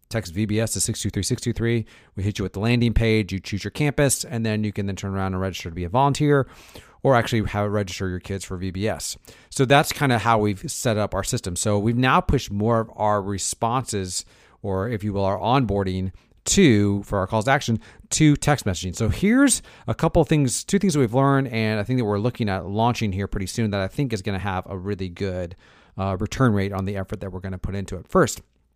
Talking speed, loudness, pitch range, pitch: 240 wpm, -23 LUFS, 95-120 Hz, 105 Hz